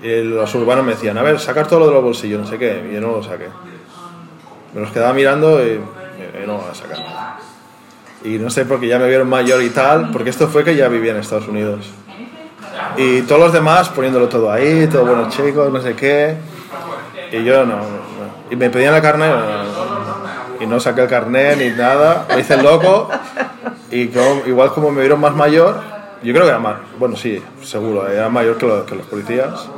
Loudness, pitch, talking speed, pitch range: -14 LUFS, 125 Hz, 220 wpm, 115-150 Hz